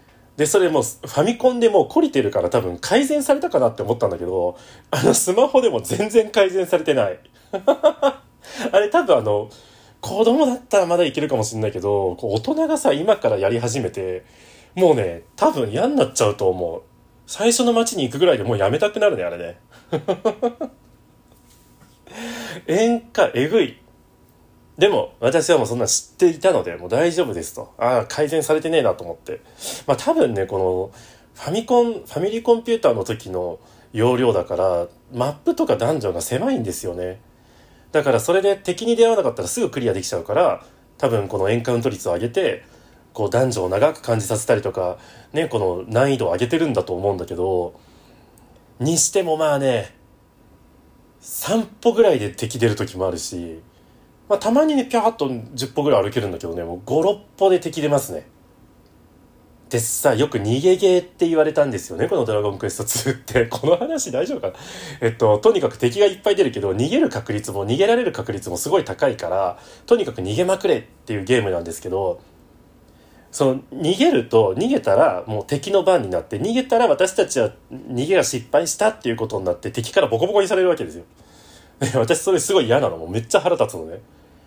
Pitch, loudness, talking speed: 165 Hz, -20 LUFS, 380 characters per minute